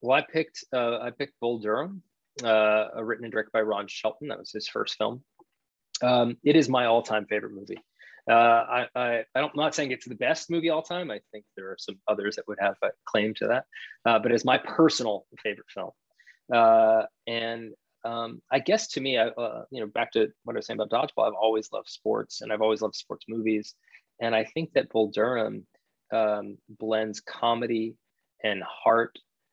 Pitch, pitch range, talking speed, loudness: 115 Hz, 110-125 Hz, 205 wpm, -27 LUFS